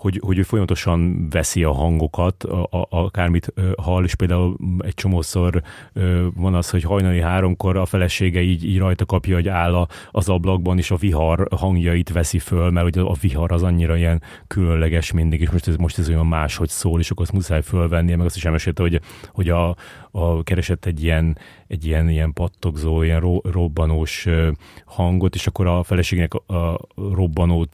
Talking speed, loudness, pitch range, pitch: 195 wpm, -20 LUFS, 85-95 Hz, 90 Hz